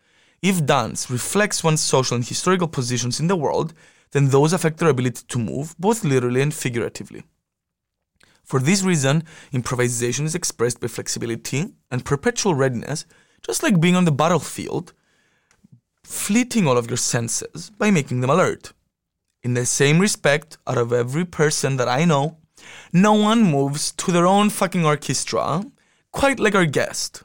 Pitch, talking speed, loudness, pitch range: 155 Hz, 155 wpm, -20 LUFS, 130-185 Hz